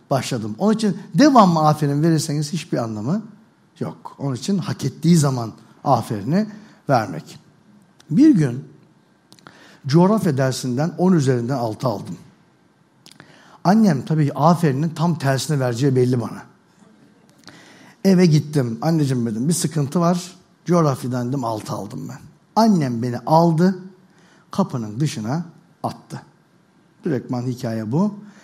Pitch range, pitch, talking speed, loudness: 130-180 Hz, 155 Hz, 115 wpm, -19 LUFS